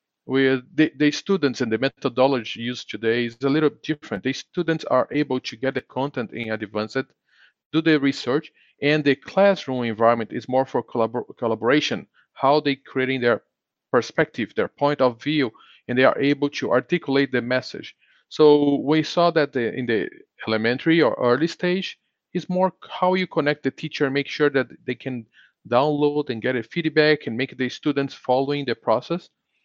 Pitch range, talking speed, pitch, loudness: 125-150 Hz, 175 wpm, 135 Hz, -22 LUFS